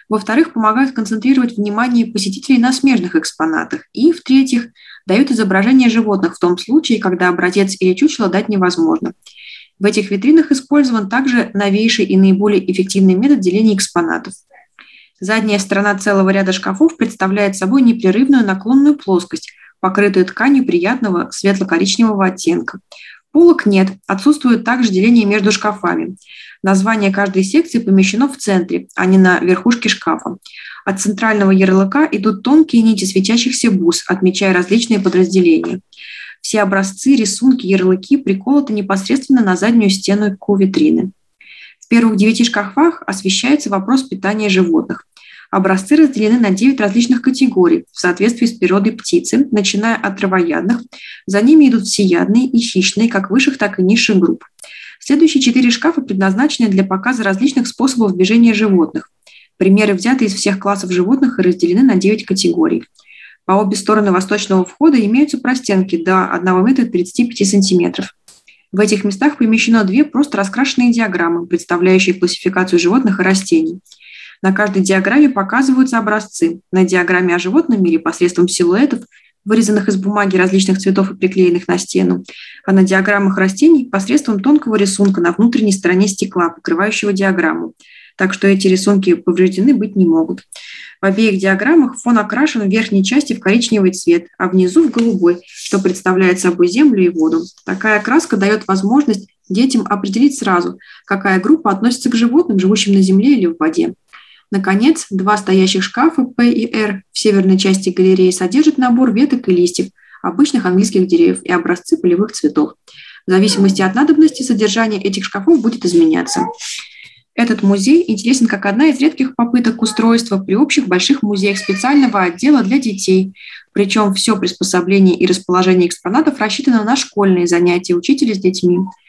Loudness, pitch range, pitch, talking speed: -13 LUFS, 190-250 Hz, 205 Hz, 145 wpm